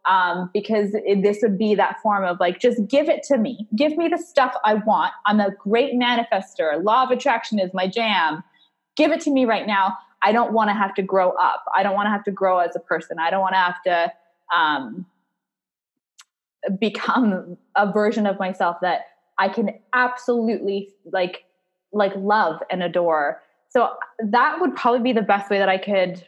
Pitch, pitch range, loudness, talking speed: 205 Hz, 190-235 Hz, -21 LUFS, 200 wpm